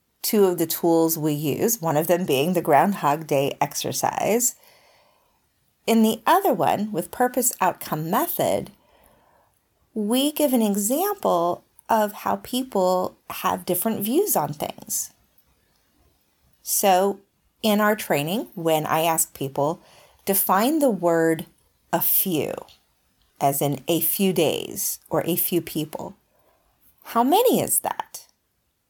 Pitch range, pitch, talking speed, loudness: 165-225 Hz, 185 Hz, 125 wpm, -22 LUFS